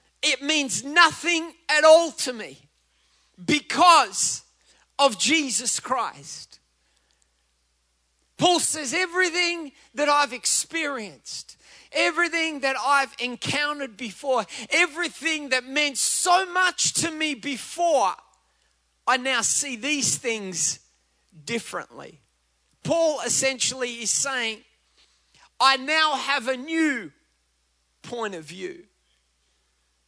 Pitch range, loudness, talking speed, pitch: 200-315 Hz, -22 LUFS, 95 wpm, 270 Hz